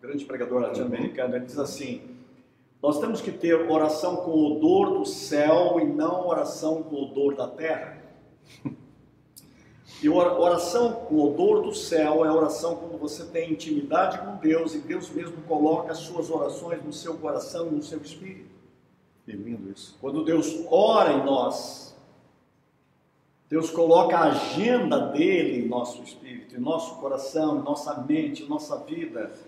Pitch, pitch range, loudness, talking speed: 160 Hz, 150-180 Hz, -25 LUFS, 155 wpm